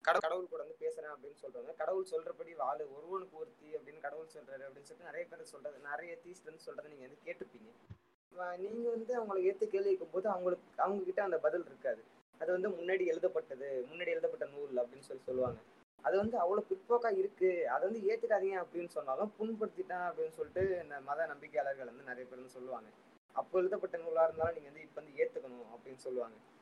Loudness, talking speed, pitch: -38 LUFS, 180 wpm, 195 Hz